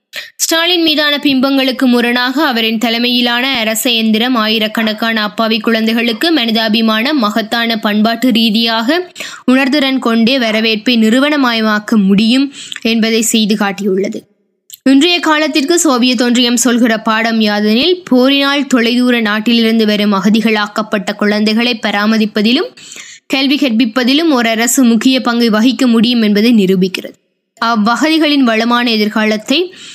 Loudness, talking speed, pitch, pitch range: -11 LUFS, 100 wpm, 235 Hz, 220-260 Hz